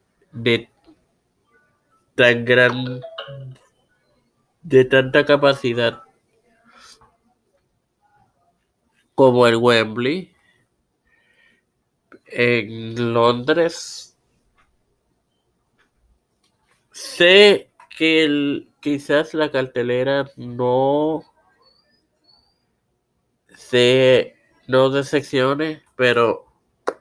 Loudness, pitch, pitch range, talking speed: -17 LUFS, 130 Hz, 120-145 Hz, 50 wpm